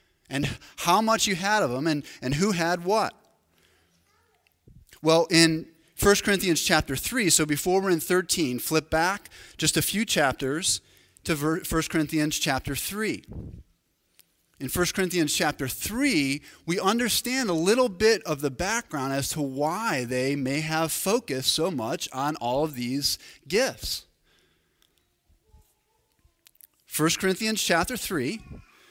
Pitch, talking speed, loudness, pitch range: 160 Hz, 135 wpm, -25 LUFS, 135-185 Hz